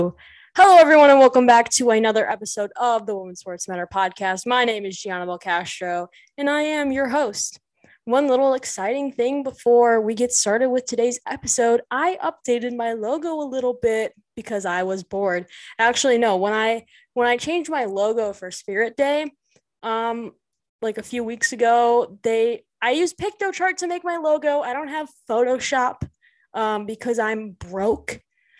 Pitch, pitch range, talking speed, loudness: 240 Hz, 215-285 Hz, 170 wpm, -20 LUFS